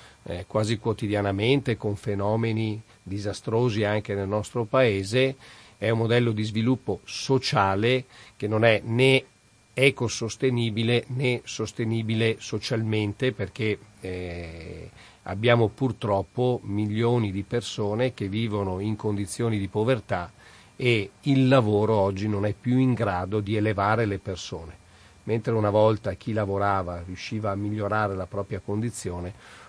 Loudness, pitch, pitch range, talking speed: -25 LUFS, 110 Hz, 100-115 Hz, 125 wpm